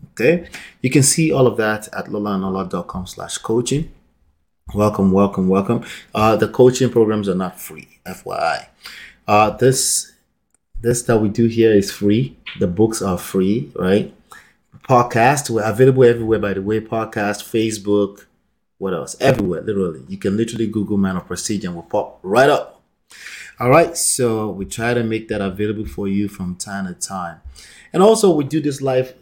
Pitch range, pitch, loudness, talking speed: 100-120 Hz, 110 Hz, -18 LUFS, 170 wpm